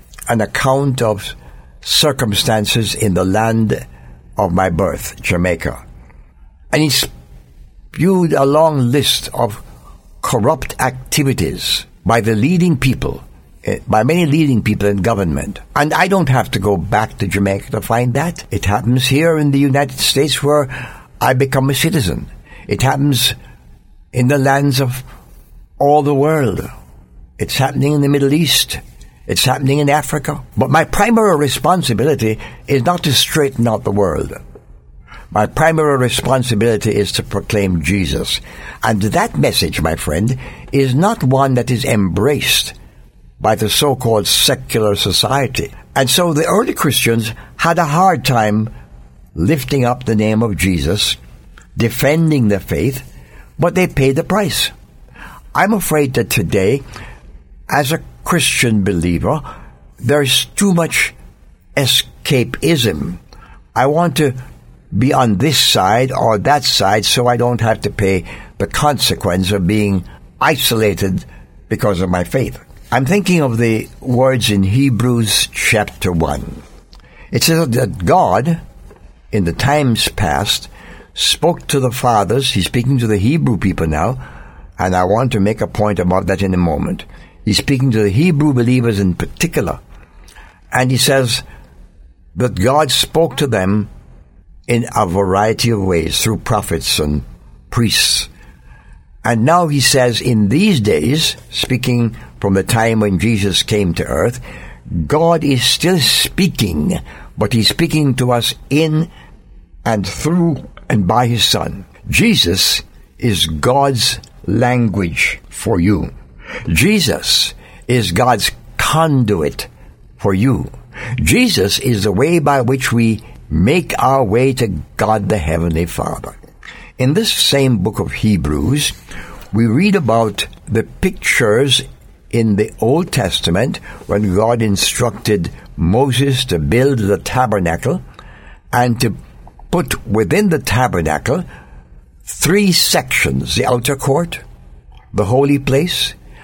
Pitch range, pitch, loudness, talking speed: 95-140 Hz, 115 Hz, -14 LUFS, 135 wpm